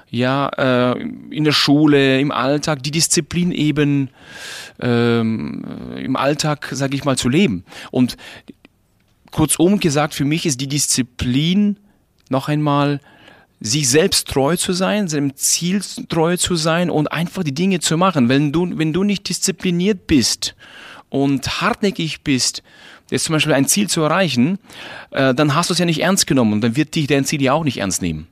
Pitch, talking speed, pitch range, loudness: 150 Hz, 165 wpm, 135-175 Hz, -17 LUFS